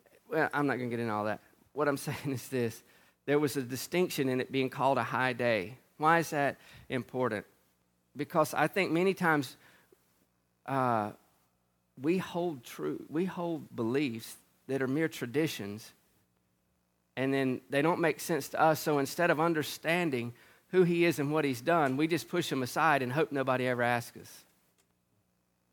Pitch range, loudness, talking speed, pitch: 115-155 Hz, -31 LUFS, 175 wpm, 135 Hz